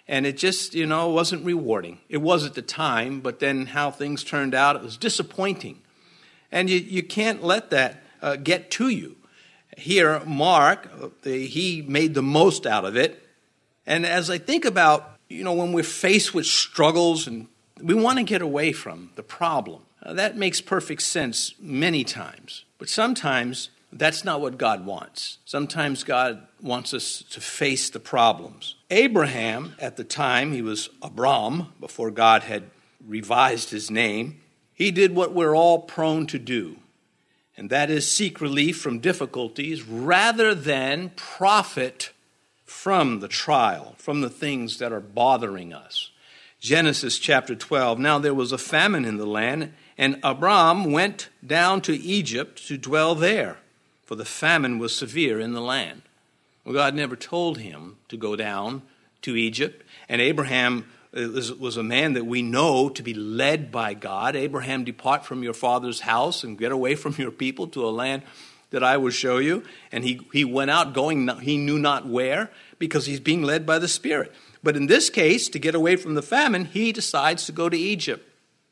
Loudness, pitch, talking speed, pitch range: -23 LUFS, 145 Hz, 175 wpm, 125-170 Hz